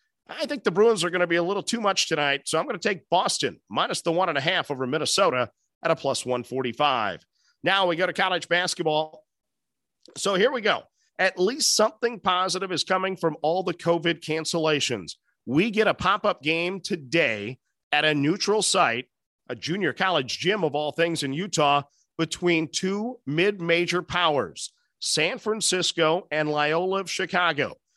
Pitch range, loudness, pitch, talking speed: 155-195 Hz, -24 LUFS, 175 Hz, 175 wpm